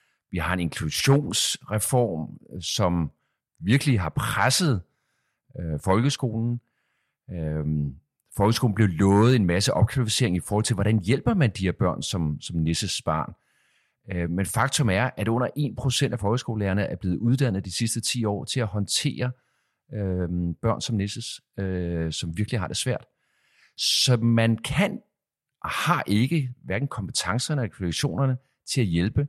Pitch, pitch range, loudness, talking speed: 110 Hz, 90-125 Hz, -25 LUFS, 150 wpm